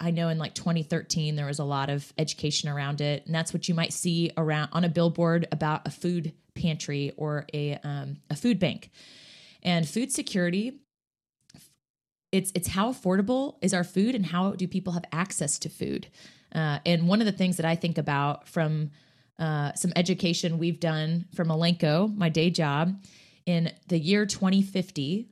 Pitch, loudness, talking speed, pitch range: 170 Hz, -28 LUFS, 180 wpm, 155-180 Hz